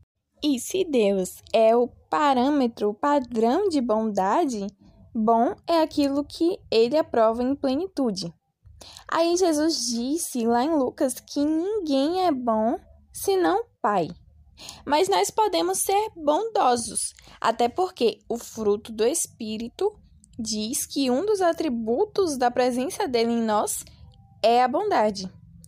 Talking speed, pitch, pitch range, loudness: 125 wpm, 260 Hz, 225-335 Hz, -24 LUFS